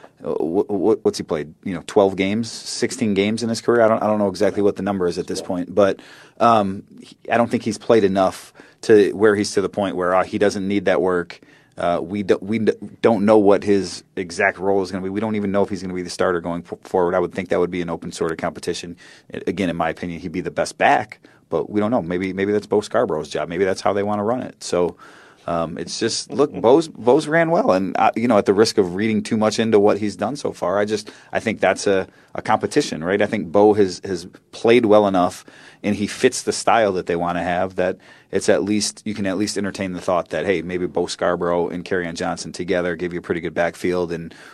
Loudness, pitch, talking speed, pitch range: -20 LUFS, 100 Hz, 260 wpm, 90-105 Hz